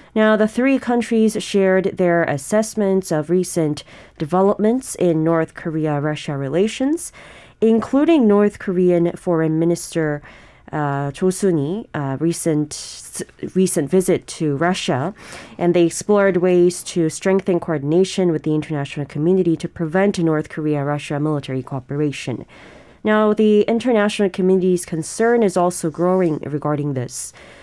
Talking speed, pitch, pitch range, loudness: 120 wpm, 175 Hz, 155-200 Hz, -19 LUFS